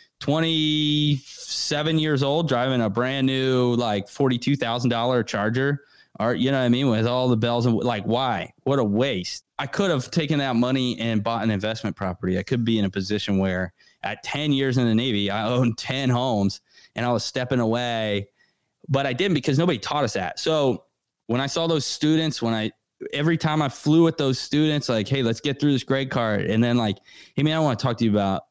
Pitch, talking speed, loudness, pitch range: 125 Hz, 215 wpm, -23 LUFS, 115-145 Hz